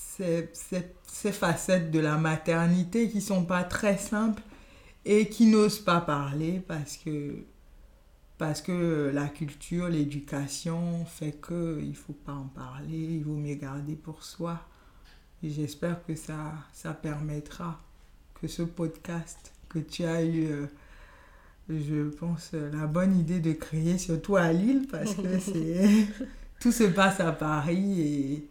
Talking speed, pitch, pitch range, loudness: 145 wpm, 165 Hz, 150-180 Hz, -29 LUFS